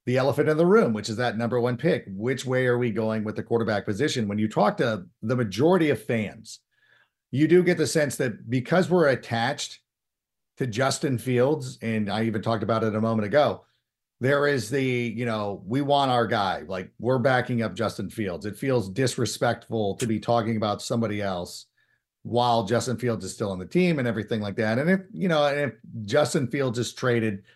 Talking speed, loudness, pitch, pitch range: 205 wpm, -25 LUFS, 120 Hz, 110-135 Hz